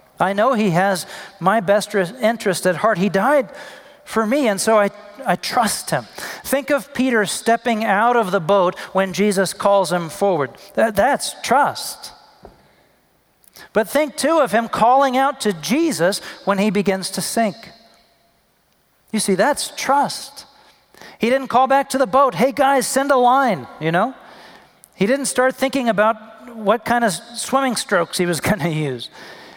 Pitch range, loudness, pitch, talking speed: 200-270 Hz, -18 LUFS, 225 Hz, 165 wpm